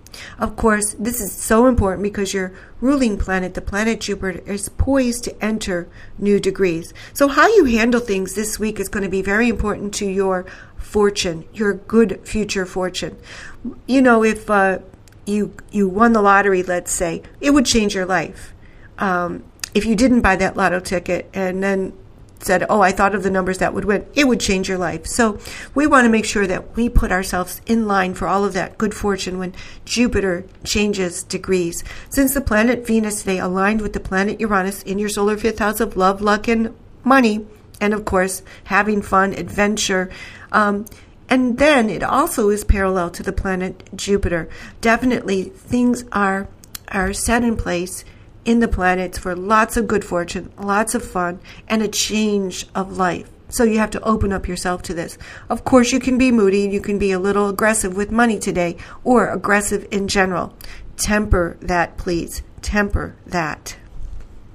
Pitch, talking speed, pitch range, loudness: 200 Hz, 180 wpm, 185-220 Hz, -18 LUFS